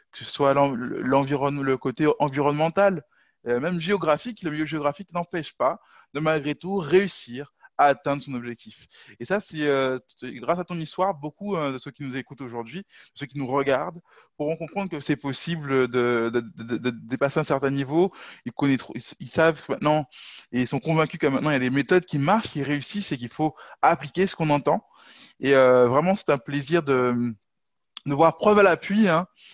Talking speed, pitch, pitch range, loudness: 195 wpm, 145 Hz, 135-165 Hz, -24 LUFS